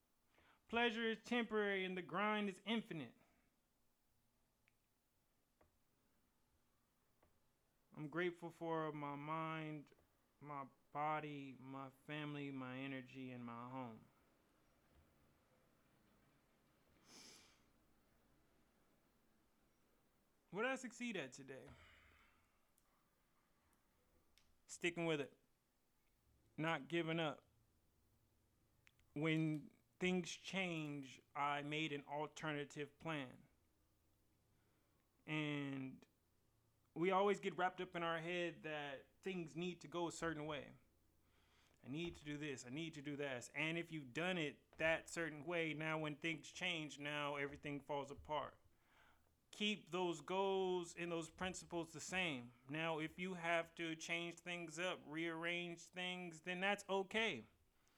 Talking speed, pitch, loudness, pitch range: 110 wpm, 155 Hz, -45 LUFS, 130-170 Hz